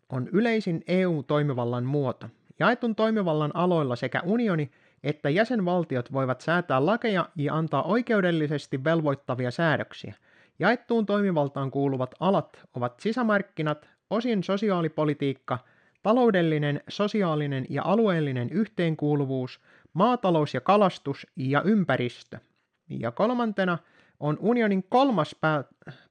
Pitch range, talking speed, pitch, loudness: 140-205 Hz, 100 wpm, 160 Hz, -26 LUFS